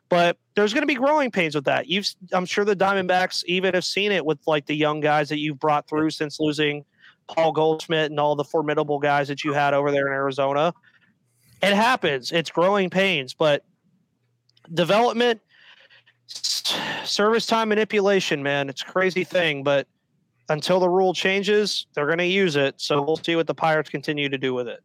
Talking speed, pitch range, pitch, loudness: 190 wpm, 145-190 Hz, 160 Hz, -22 LUFS